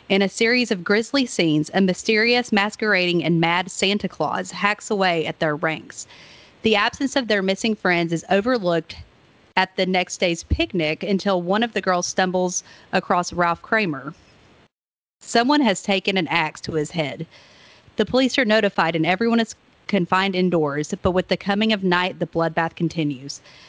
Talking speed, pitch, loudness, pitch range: 165 wpm, 185 Hz, -21 LUFS, 170-210 Hz